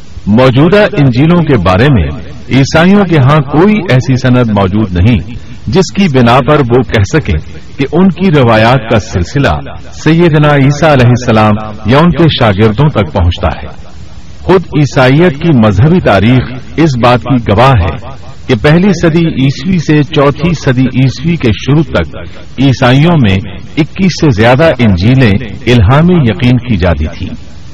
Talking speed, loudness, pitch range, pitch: 150 wpm, -8 LUFS, 105-155 Hz, 130 Hz